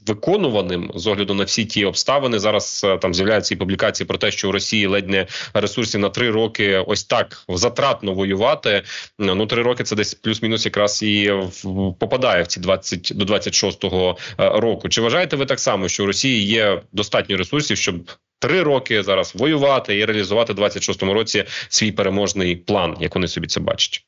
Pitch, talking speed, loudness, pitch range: 105 Hz, 180 wpm, -19 LUFS, 95-110 Hz